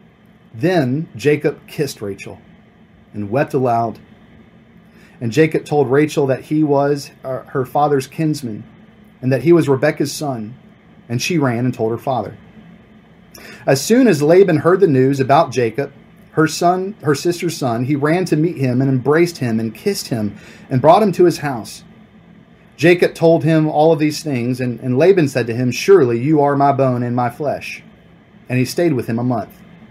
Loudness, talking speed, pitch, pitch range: -16 LUFS, 180 wpm, 145 Hz, 125-170 Hz